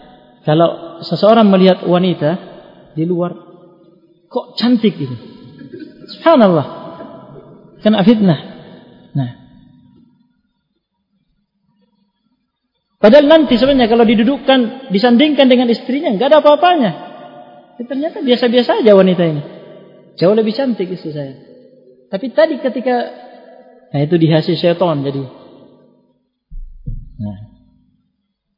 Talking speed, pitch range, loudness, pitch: 95 wpm, 170-245 Hz, -13 LUFS, 200 Hz